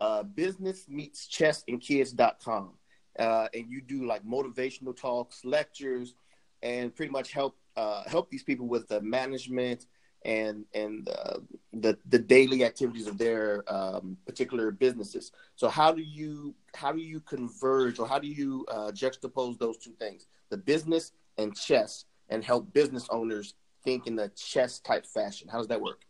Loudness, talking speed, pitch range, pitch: -30 LUFS, 165 wpm, 115-145 Hz, 130 Hz